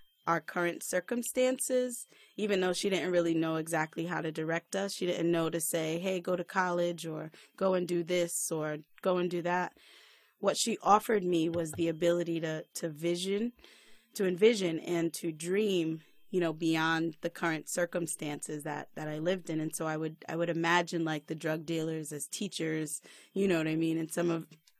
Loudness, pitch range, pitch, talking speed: -32 LUFS, 160-180 Hz, 170 Hz, 195 wpm